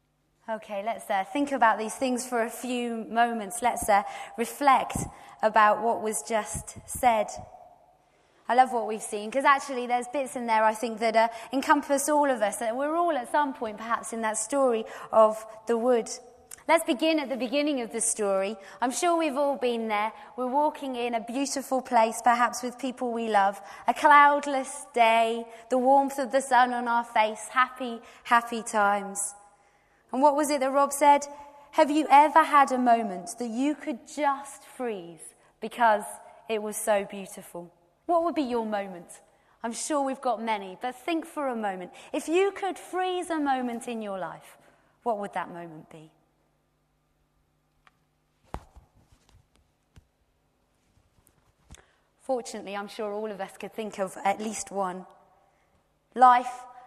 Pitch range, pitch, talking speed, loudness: 210-275 Hz, 235 Hz, 165 wpm, -26 LUFS